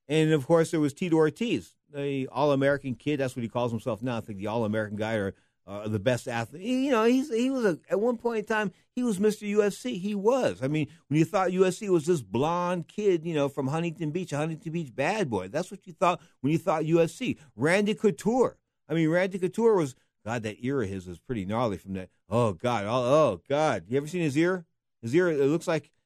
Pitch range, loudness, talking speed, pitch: 125-185 Hz, -27 LUFS, 235 wpm, 155 Hz